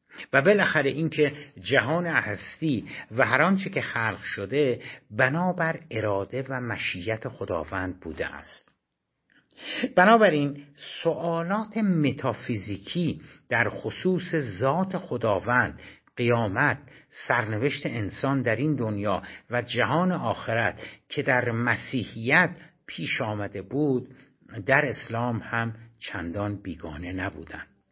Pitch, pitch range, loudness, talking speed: 130 Hz, 110-155 Hz, -26 LUFS, 100 wpm